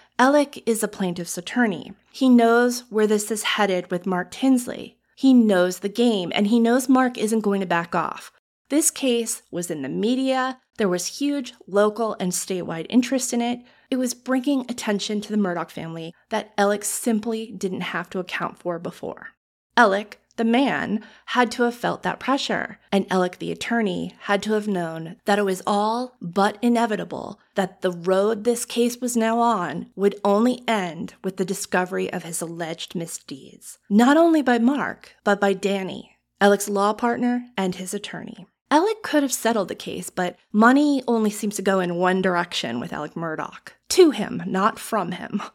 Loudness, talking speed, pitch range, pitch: -22 LUFS, 180 wpm, 190-240 Hz, 210 Hz